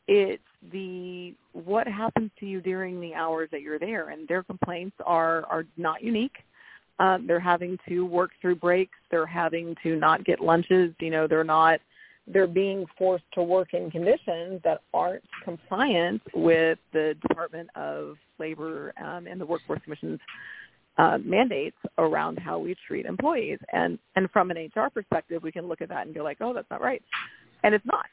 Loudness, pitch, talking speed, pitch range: -27 LUFS, 175 Hz, 180 wpm, 165-190 Hz